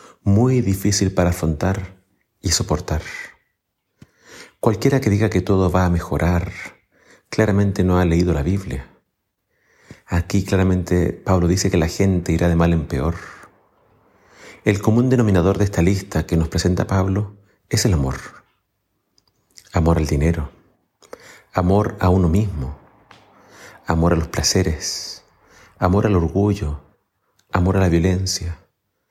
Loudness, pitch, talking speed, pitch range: -19 LUFS, 90 Hz, 130 wpm, 85-100 Hz